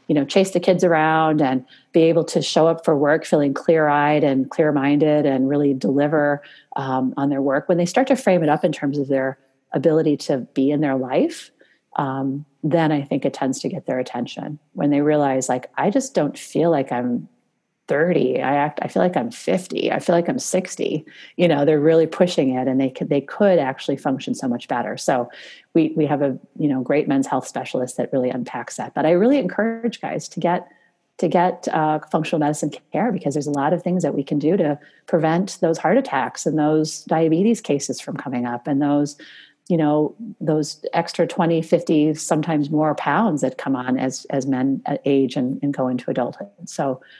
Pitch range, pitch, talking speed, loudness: 140-170 Hz, 150 Hz, 210 wpm, -20 LUFS